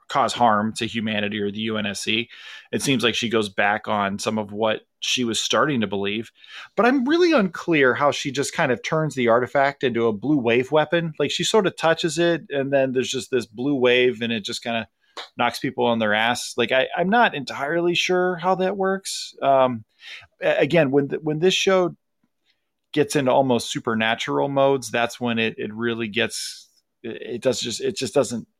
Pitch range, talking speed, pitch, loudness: 115-165 Hz, 200 wpm, 130 Hz, -21 LUFS